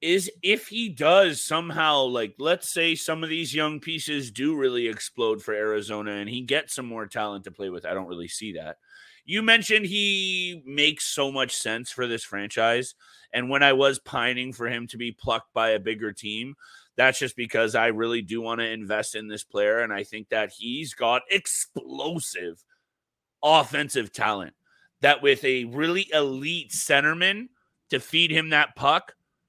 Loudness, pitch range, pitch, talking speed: -24 LUFS, 115-185 Hz, 145 Hz, 180 wpm